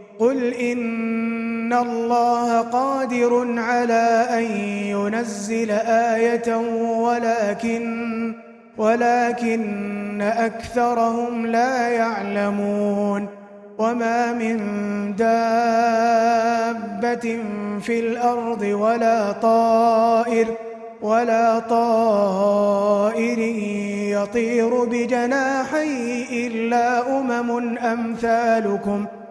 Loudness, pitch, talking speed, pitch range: -20 LUFS, 230 Hz, 55 wpm, 220-235 Hz